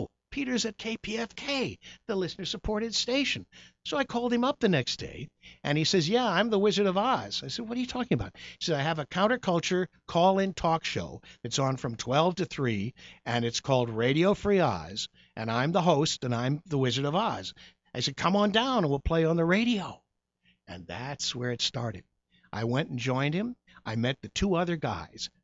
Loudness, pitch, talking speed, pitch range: -29 LUFS, 165 Hz, 210 wpm, 125-210 Hz